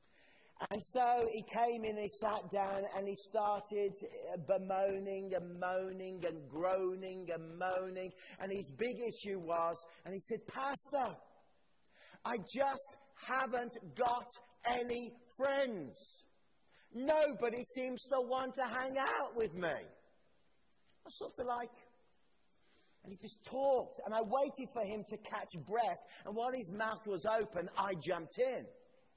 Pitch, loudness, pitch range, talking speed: 220 Hz, -39 LUFS, 195-250 Hz, 140 wpm